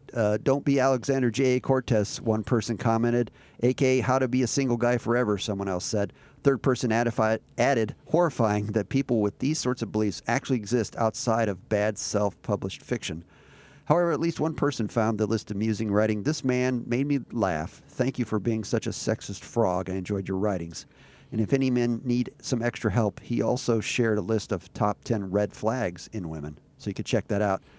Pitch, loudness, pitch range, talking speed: 115 Hz, -27 LUFS, 105-125 Hz, 200 wpm